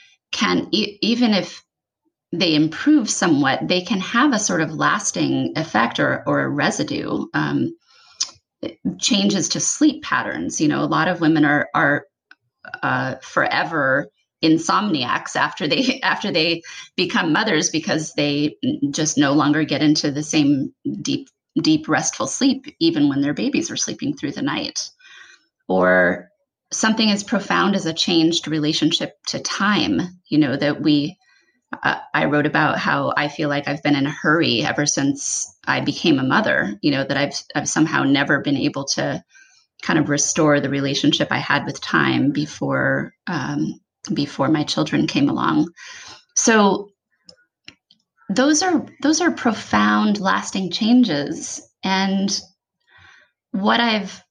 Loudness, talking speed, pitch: -19 LUFS, 145 wpm, 180 Hz